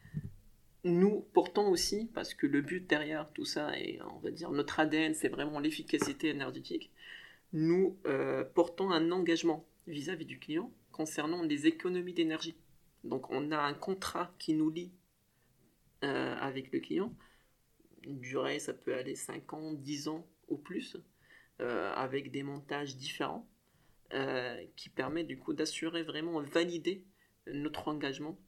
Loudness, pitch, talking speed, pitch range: -36 LUFS, 160 Hz, 145 wpm, 145-180 Hz